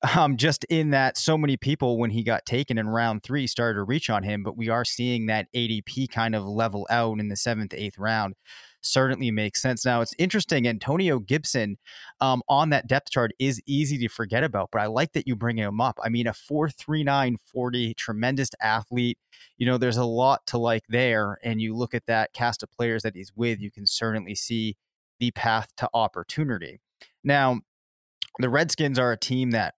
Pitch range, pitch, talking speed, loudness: 110-130 Hz, 120 Hz, 205 wpm, -25 LUFS